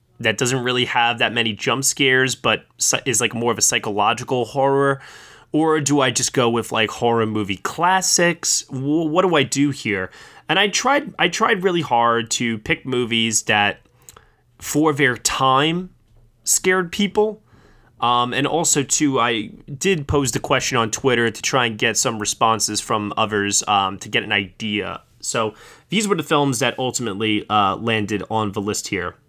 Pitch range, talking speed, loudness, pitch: 110-145 Hz, 170 wpm, -19 LUFS, 120 Hz